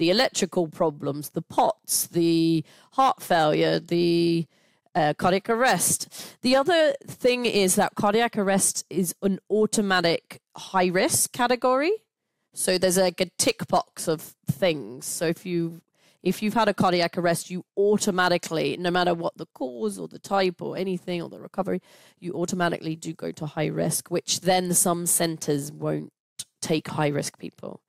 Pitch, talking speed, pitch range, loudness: 180 Hz, 155 wpm, 170-200 Hz, -24 LUFS